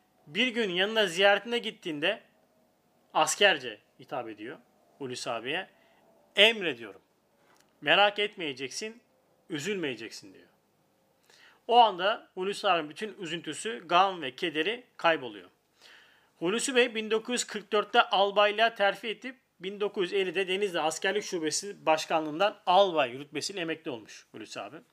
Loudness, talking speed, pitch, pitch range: -28 LUFS, 100 wpm, 205 Hz, 175-225 Hz